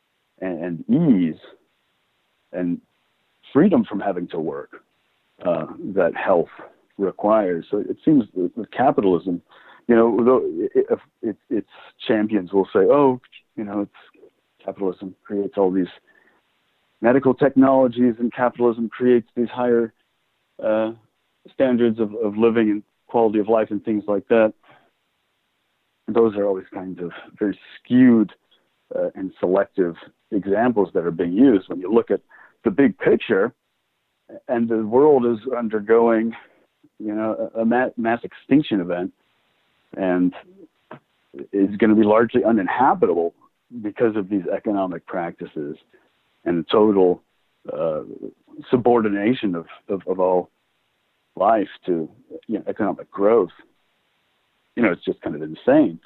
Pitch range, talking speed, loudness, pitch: 100-120 Hz, 130 wpm, -20 LUFS, 110 Hz